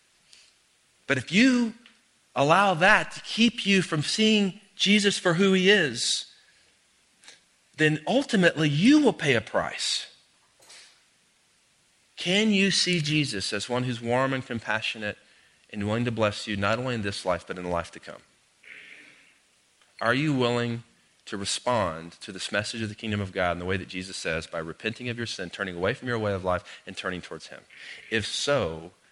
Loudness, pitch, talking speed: -25 LUFS, 125 Hz, 175 wpm